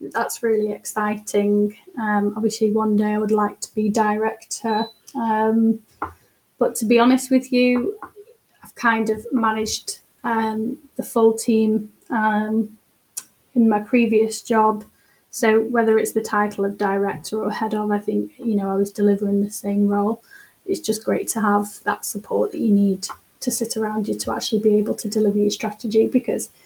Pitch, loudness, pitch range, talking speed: 220 Hz, -21 LUFS, 210-230 Hz, 170 wpm